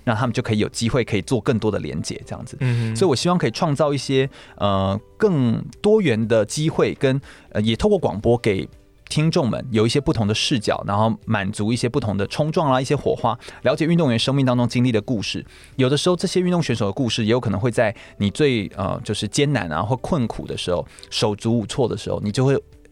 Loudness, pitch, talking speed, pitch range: -21 LUFS, 120 Hz, 340 characters per minute, 105-145 Hz